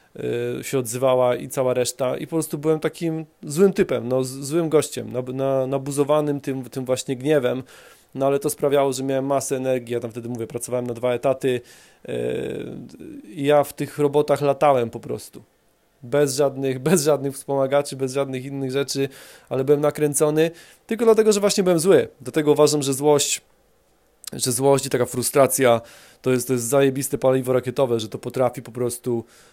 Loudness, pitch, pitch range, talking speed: -21 LUFS, 135 Hz, 130-150 Hz, 170 wpm